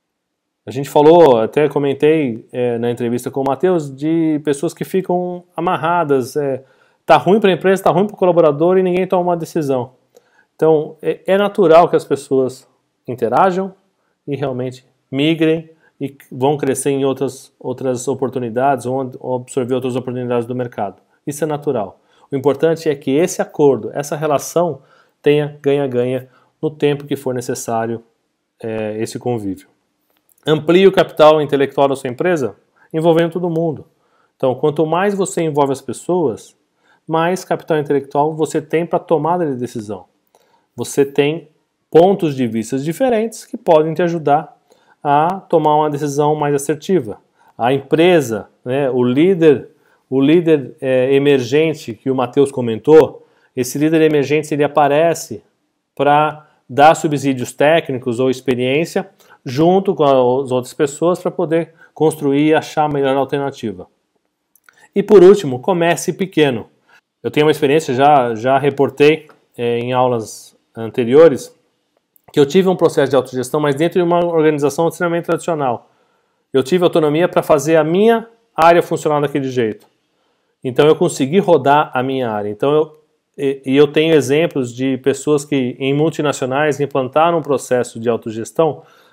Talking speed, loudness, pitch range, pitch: 150 wpm, -15 LUFS, 135-165 Hz, 150 Hz